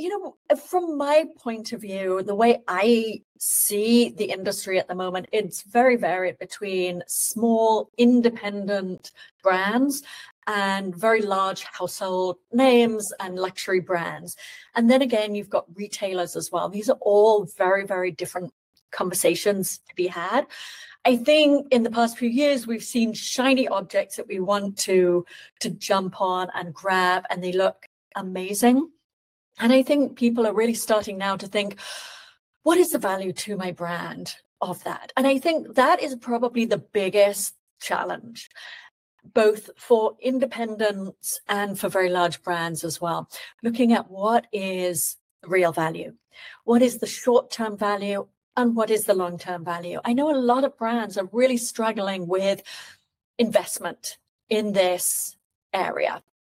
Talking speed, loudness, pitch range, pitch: 155 wpm, -23 LUFS, 190-235 Hz, 205 Hz